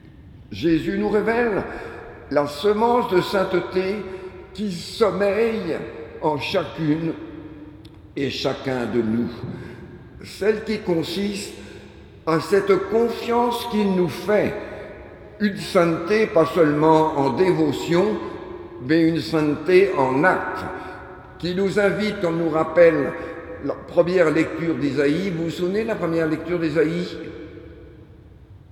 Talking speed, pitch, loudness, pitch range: 110 wpm, 170 Hz, -21 LUFS, 155-200 Hz